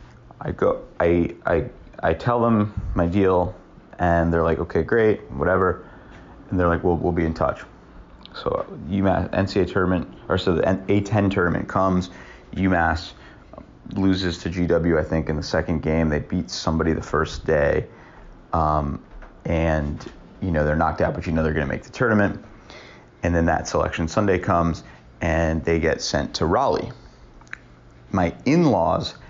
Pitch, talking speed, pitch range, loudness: 85 Hz, 160 wpm, 80-95 Hz, -22 LUFS